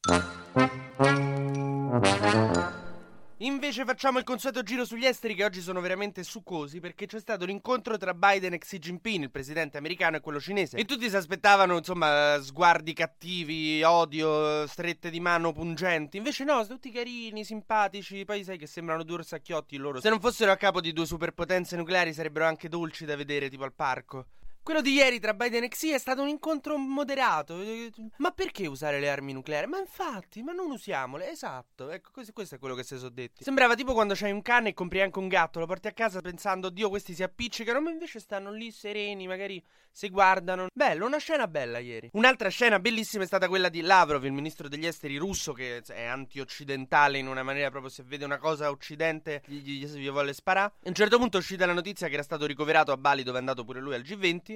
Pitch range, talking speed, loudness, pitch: 150-220 Hz, 200 wpm, -28 LUFS, 180 Hz